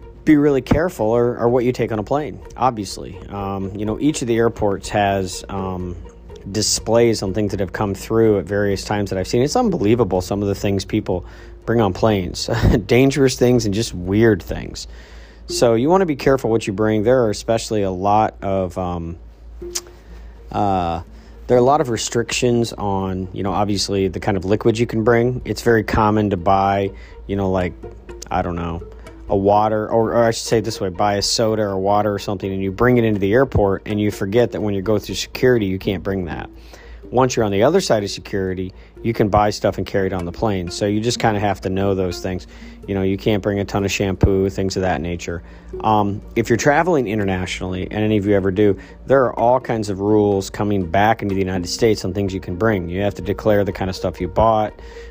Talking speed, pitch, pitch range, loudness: 230 wpm, 100 Hz, 95-115 Hz, -19 LUFS